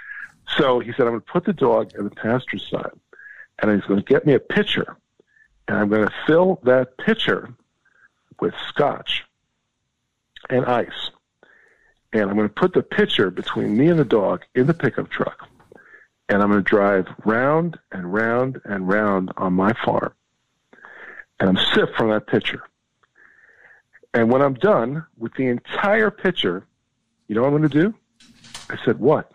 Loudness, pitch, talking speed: -20 LUFS, 125 Hz, 175 wpm